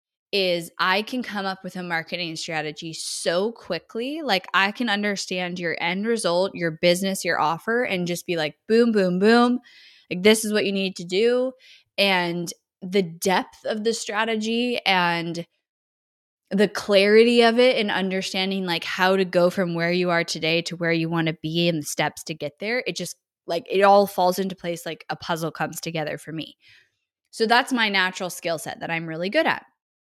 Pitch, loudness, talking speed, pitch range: 185 Hz, -22 LUFS, 195 wpm, 170-205 Hz